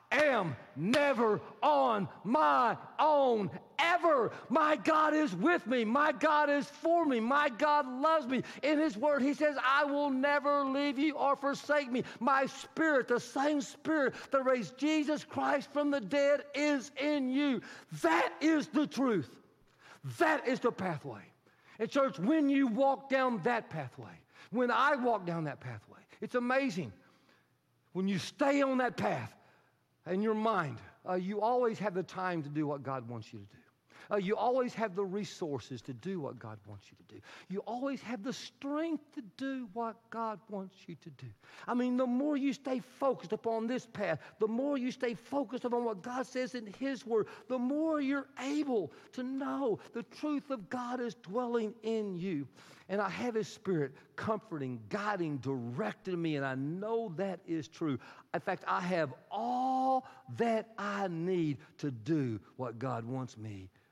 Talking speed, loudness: 175 wpm, -33 LUFS